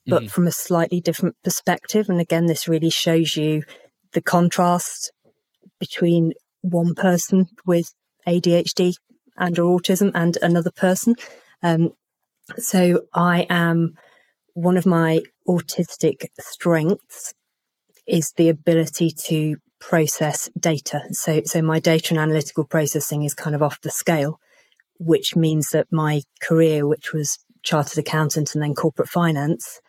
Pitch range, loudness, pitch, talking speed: 155-180 Hz, -20 LUFS, 170 Hz, 130 wpm